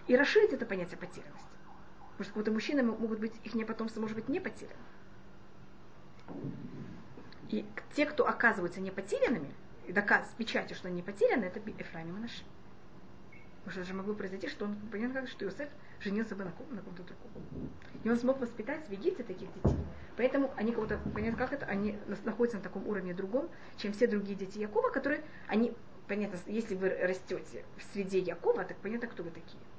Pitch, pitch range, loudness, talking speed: 215 Hz, 195-240 Hz, -35 LUFS, 185 wpm